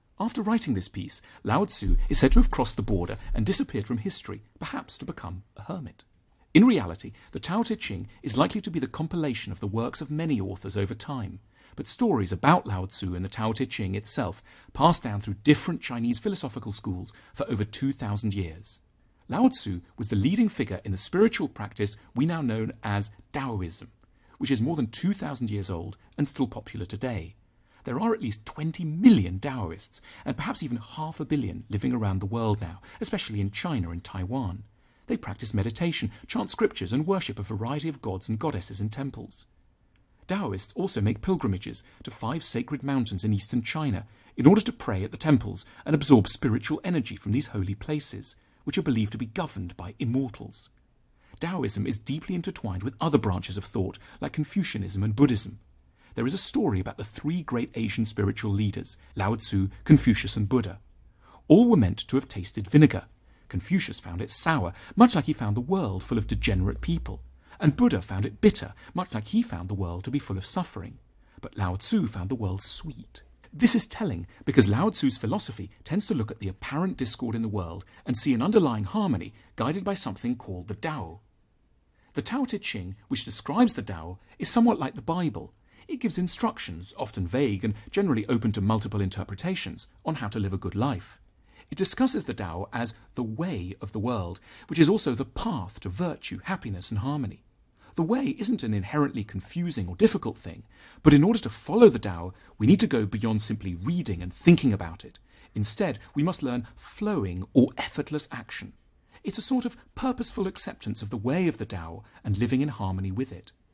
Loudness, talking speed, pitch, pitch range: -27 LUFS, 195 wpm, 115 Hz, 100-150 Hz